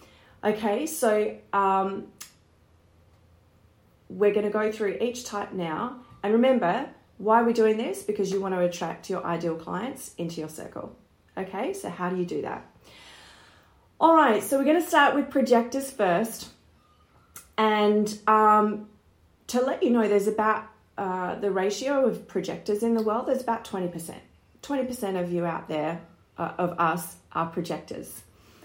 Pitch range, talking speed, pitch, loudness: 170-230 Hz, 155 wpm, 210 Hz, -26 LUFS